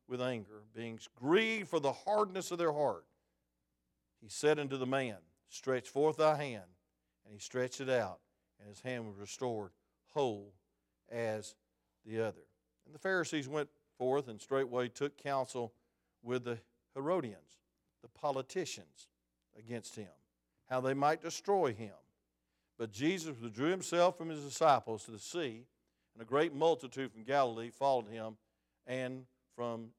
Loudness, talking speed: -37 LUFS, 150 wpm